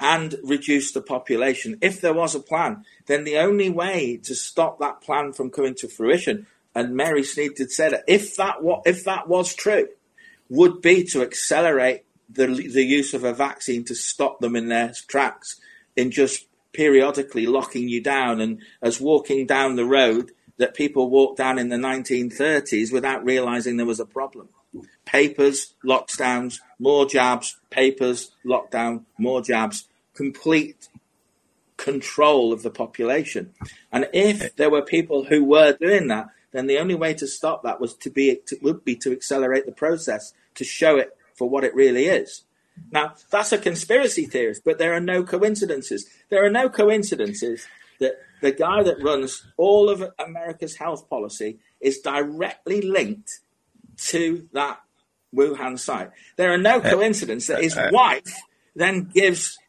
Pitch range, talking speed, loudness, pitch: 130-180 Hz, 165 wpm, -21 LUFS, 145 Hz